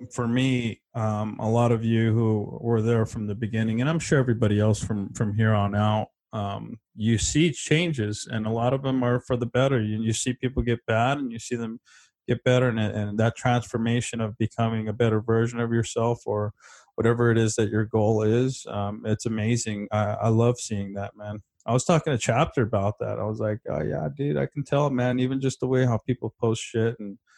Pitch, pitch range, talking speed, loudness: 115 Hz, 110-125 Hz, 225 wpm, -25 LUFS